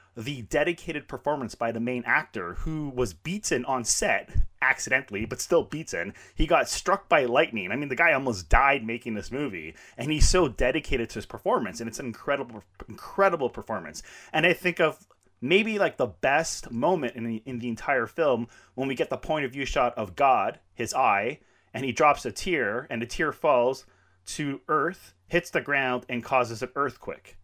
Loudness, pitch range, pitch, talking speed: -26 LUFS, 115-150 Hz, 125 Hz, 190 wpm